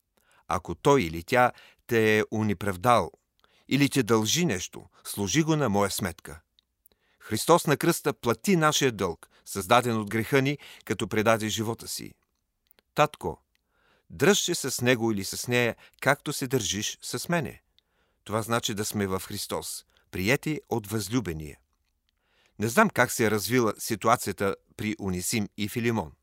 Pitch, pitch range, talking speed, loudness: 115 Hz, 105-135 Hz, 145 wpm, -26 LUFS